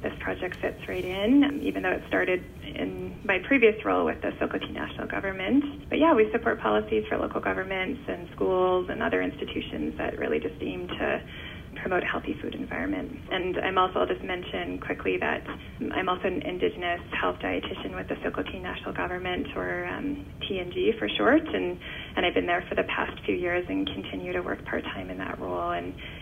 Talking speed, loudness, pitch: 195 wpm, -28 LUFS, 180 Hz